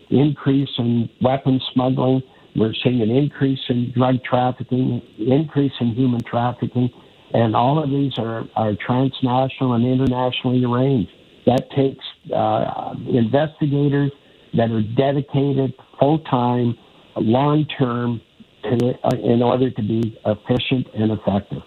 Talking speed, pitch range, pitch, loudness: 120 wpm, 120-135 Hz, 125 Hz, -20 LUFS